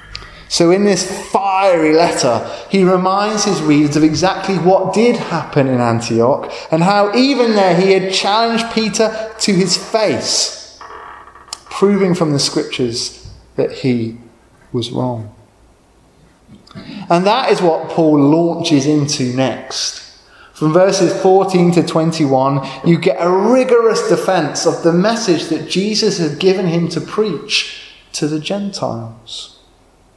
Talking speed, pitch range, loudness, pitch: 130 wpm, 145-195 Hz, -14 LUFS, 170 Hz